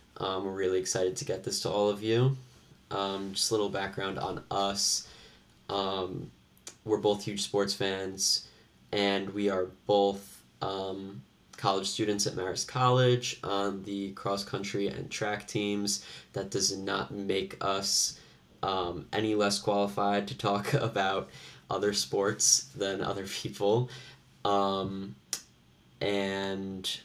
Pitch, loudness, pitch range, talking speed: 100 Hz, -30 LUFS, 95-105 Hz, 135 wpm